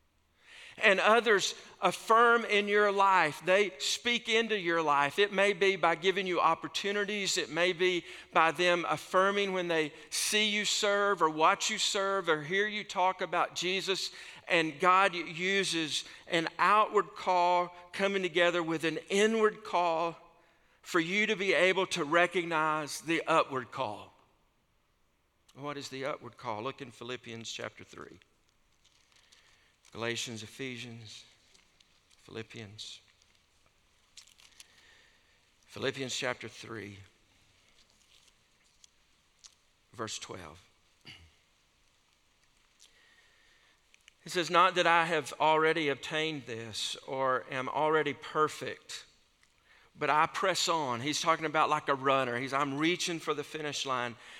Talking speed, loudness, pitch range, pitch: 120 wpm, -29 LUFS, 125-185 Hz, 160 Hz